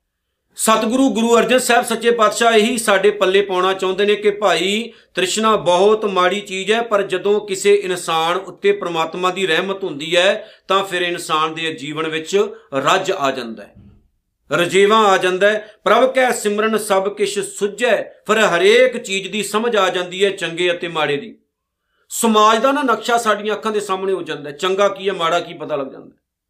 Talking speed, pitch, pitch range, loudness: 180 wpm, 195 Hz, 175-215 Hz, -16 LUFS